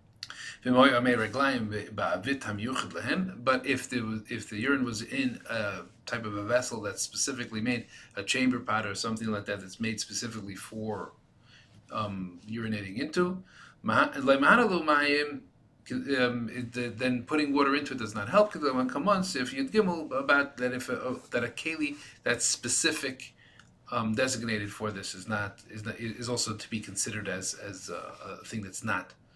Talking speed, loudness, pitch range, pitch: 155 wpm, -30 LUFS, 110-135 Hz, 120 Hz